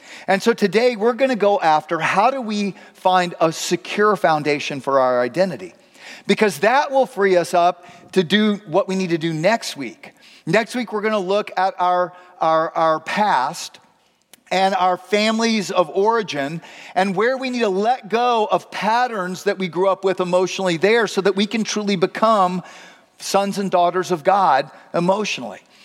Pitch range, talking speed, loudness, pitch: 180-210 Hz, 180 wpm, -19 LUFS, 190 Hz